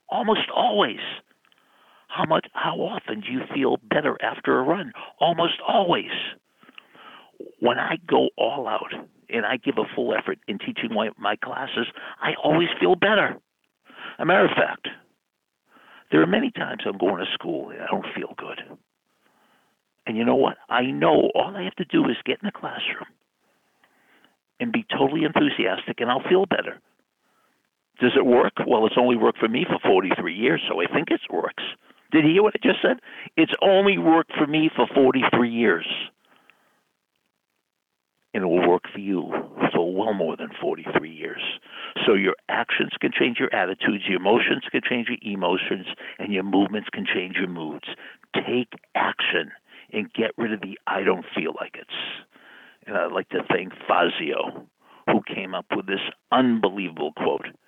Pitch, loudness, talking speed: 135 Hz, -23 LUFS, 175 wpm